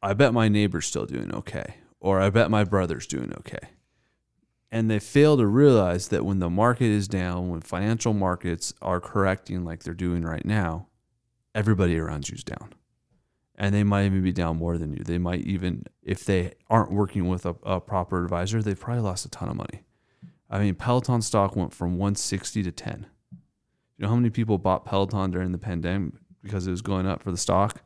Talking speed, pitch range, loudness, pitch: 205 wpm, 90-110 Hz, -25 LUFS, 100 Hz